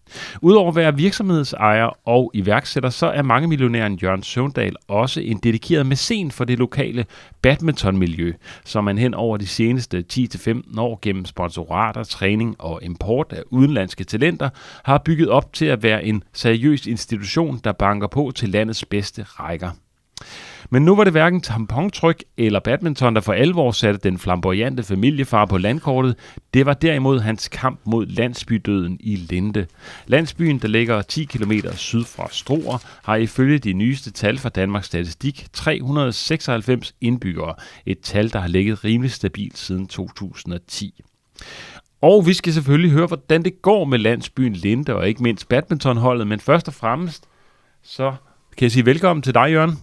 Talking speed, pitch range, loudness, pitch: 160 wpm, 105-140 Hz, -19 LUFS, 120 Hz